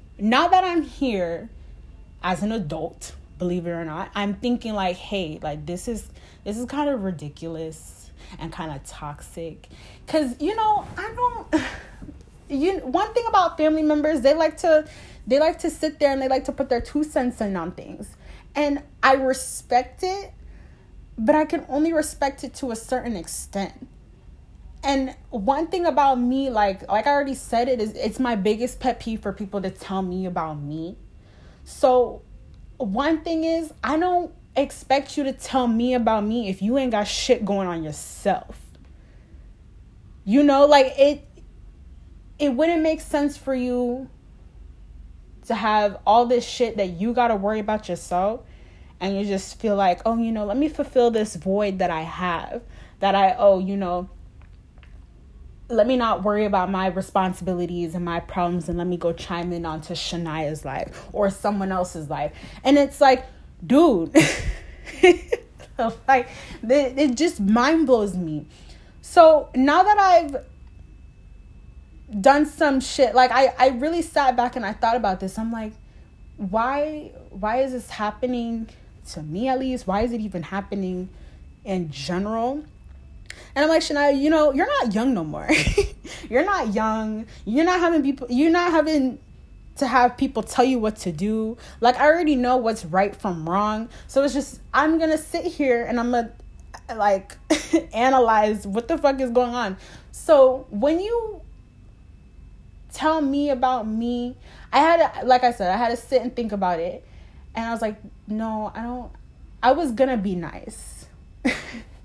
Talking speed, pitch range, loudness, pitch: 170 wpm, 195-280 Hz, -22 LUFS, 235 Hz